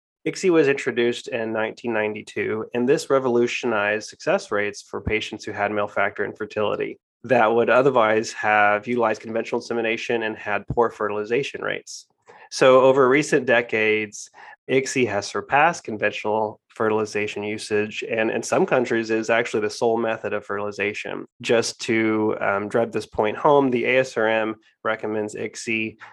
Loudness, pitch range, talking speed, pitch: -22 LUFS, 105-120 Hz, 140 wpm, 110 Hz